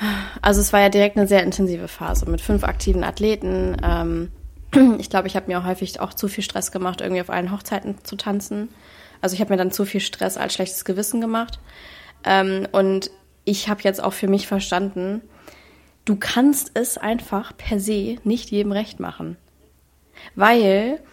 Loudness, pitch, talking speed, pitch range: -21 LUFS, 200 Hz, 175 wpm, 185-210 Hz